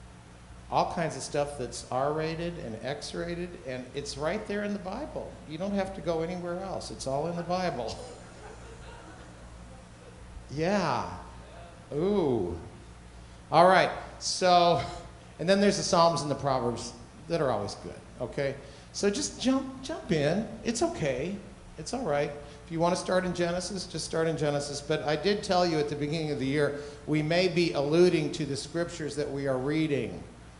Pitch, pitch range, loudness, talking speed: 150 Hz, 135-175 Hz, -29 LUFS, 175 wpm